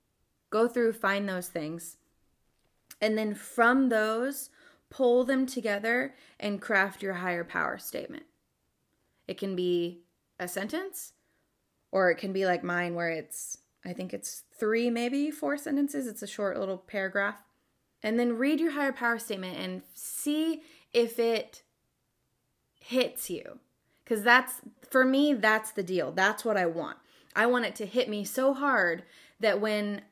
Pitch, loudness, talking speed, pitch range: 220 Hz, -29 LUFS, 155 wpm, 195-260 Hz